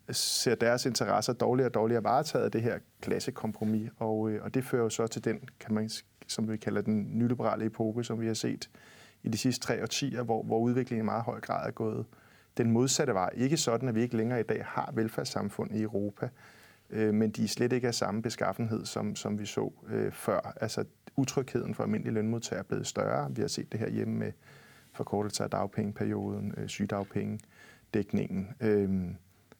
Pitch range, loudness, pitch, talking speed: 105-120 Hz, -32 LUFS, 110 Hz, 195 wpm